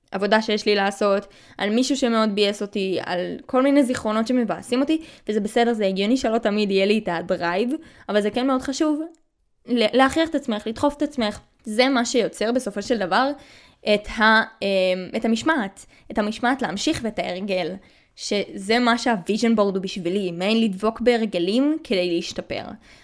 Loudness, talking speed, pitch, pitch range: -22 LUFS, 160 wpm, 220 Hz, 200-255 Hz